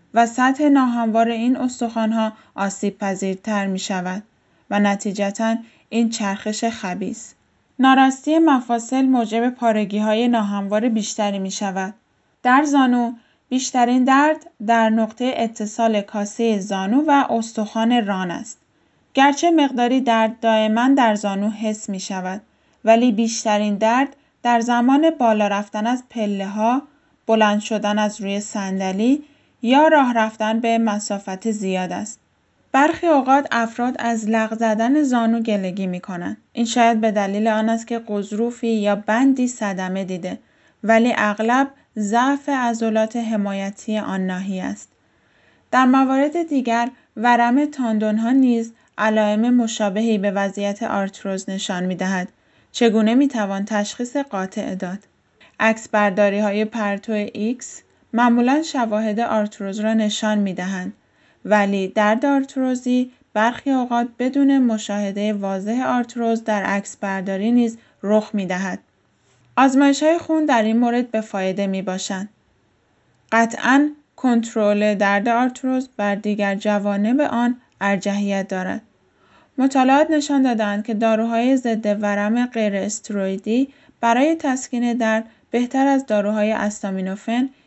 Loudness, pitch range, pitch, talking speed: -19 LUFS, 205-245 Hz, 225 Hz, 125 wpm